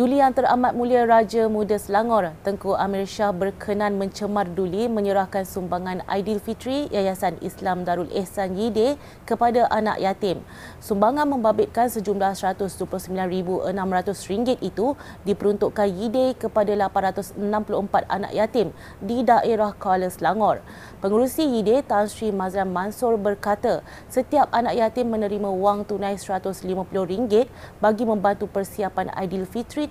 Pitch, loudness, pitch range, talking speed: 205 Hz, -23 LUFS, 190-225 Hz, 115 wpm